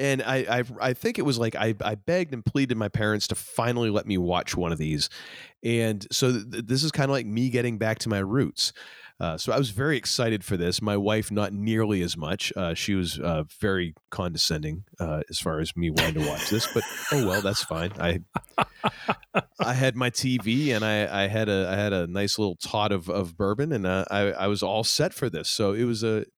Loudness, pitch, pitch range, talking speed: -26 LUFS, 105 Hz, 95-120 Hz, 235 wpm